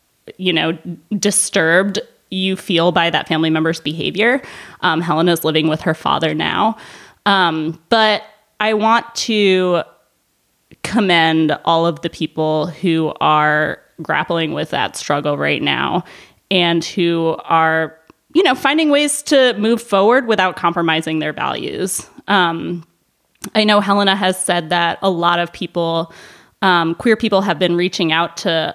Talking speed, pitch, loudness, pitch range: 140 wpm, 175 Hz, -16 LUFS, 160-205 Hz